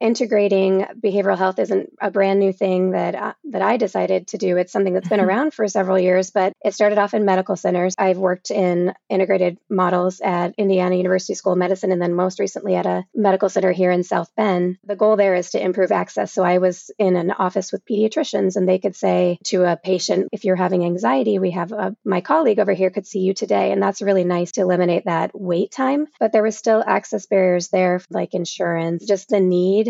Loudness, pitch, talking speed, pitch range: -19 LUFS, 190 Hz, 225 wpm, 180-200 Hz